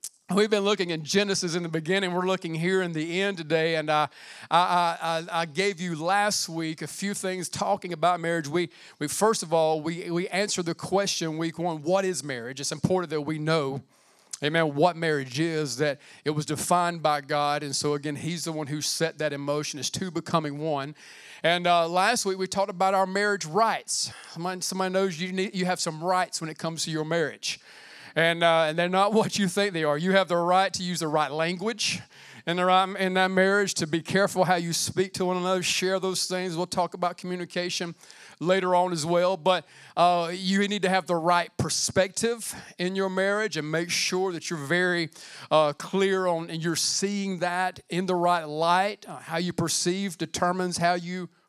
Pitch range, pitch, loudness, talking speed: 160-185 Hz, 175 Hz, -26 LUFS, 210 wpm